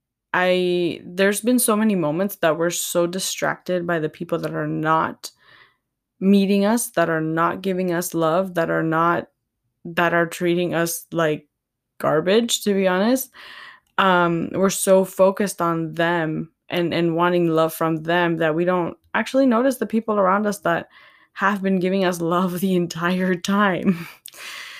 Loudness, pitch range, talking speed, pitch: -21 LUFS, 165-195 Hz, 160 wpm, 175 Hz